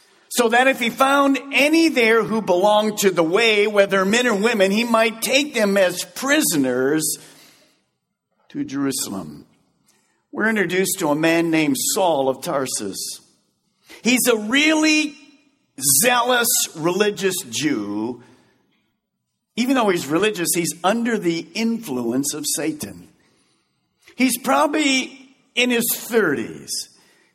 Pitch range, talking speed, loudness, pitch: 165-250 Hz, 120 wpm, -19 LUFS, 215 Hz